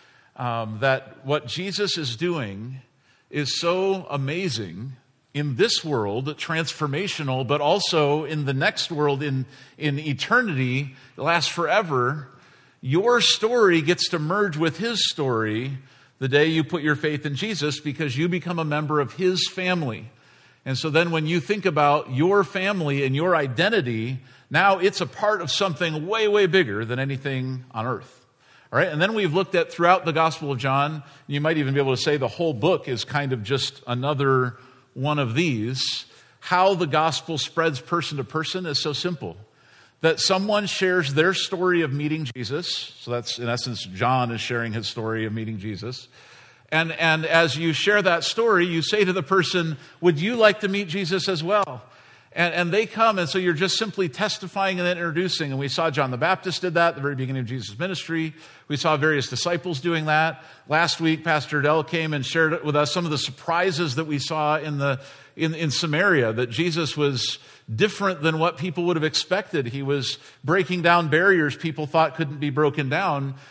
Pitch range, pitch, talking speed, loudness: 135-175 Hz, 155 Hz, 185 wpm, -23 LUFS